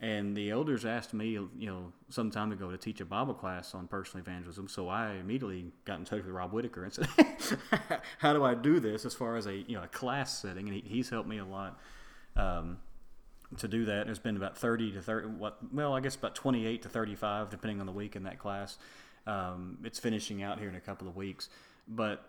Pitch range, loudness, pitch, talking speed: 95-115 Hz, -35 LUFS, 105 Hz, 230 wpm